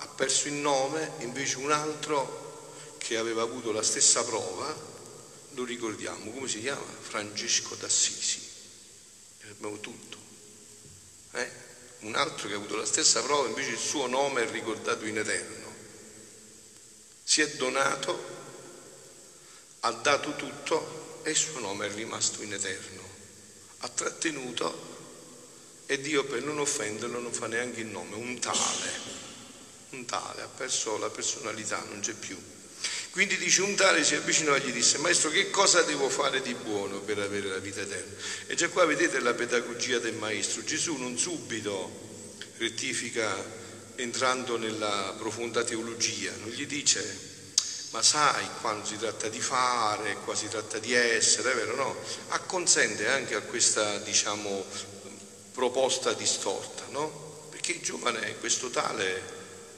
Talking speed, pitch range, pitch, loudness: 145 wpm, 105-150 Hz, 115 Hz, -28 LUFS